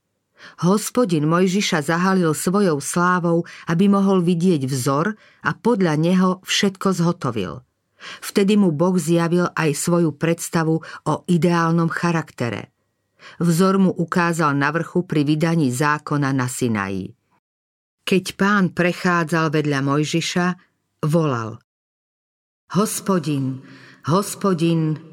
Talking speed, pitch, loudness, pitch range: 100 wpm, 170 Hz, -20 LUFS, 150-185 Hz